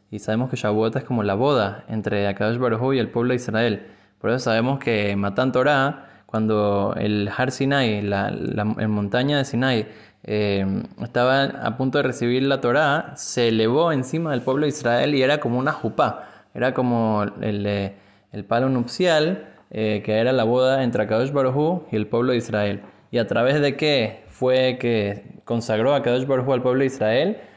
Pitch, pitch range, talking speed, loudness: 120 Hz, 105-130 Hz, 195 wpm, -22 LUFS